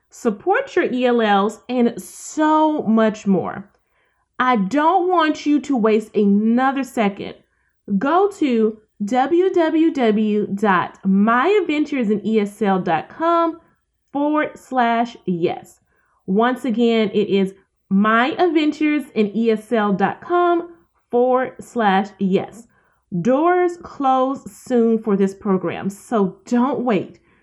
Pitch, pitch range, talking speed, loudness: 235 Hz, 205-295 Hz, 85 wpm, -19 LUFS